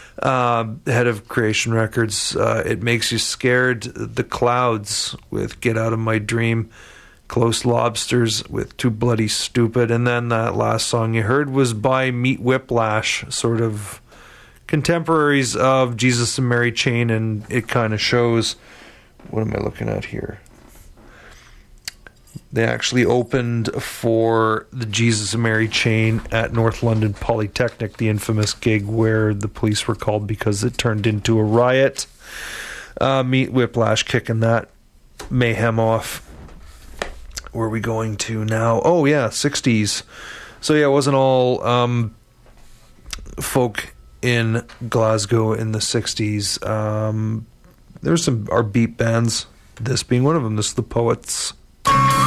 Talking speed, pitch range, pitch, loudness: 140 wpm, 110-125 Hz, 115 Hz, -19 LUFS